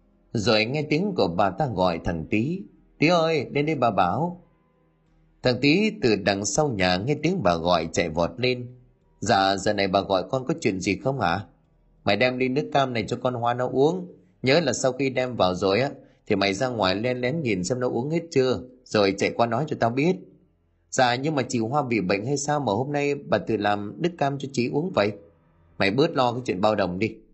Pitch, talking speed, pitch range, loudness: 120 Hz, 235 wpm, 100-145 Hz, -24 LUFS